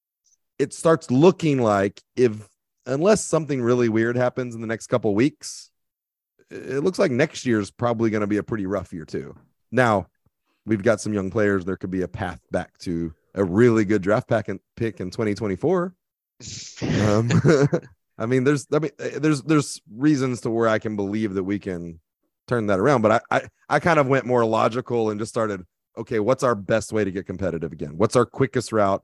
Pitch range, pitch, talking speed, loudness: 100-130 Hz, 115 Hz, 205 wpm, -22 LUFS